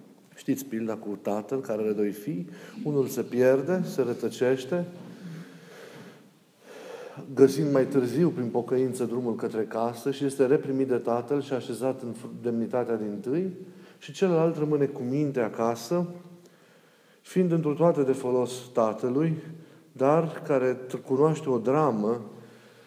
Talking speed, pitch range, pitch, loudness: 130 wpm, 120-160 Hz, 130 Hz, -27 LUFS